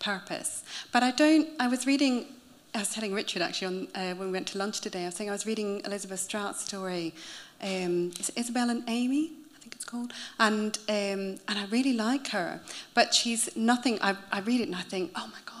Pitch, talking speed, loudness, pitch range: 220 Hz, 225 wpm, -29 LUFS, 195-245 Hz